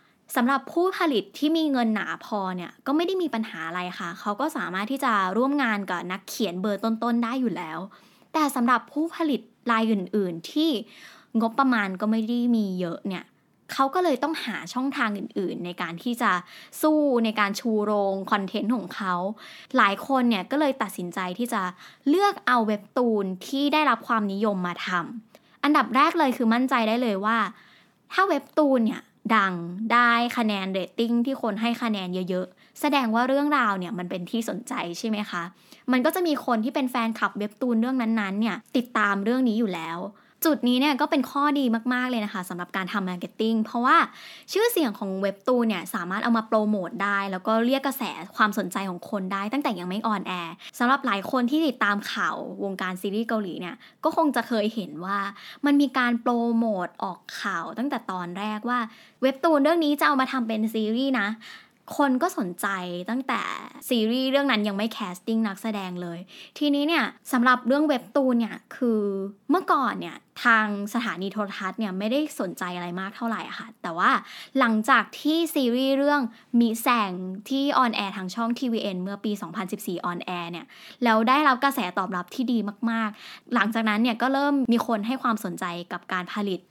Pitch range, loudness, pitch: 200-260 Hz, -25 LUFS, 225 Hz